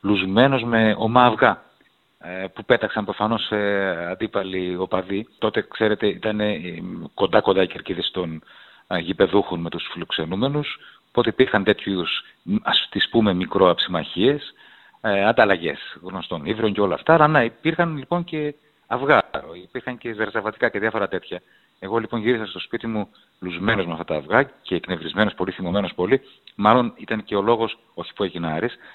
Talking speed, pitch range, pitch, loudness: 145 wpm, 95-120 Hz, 110 Hz, -21 LUFS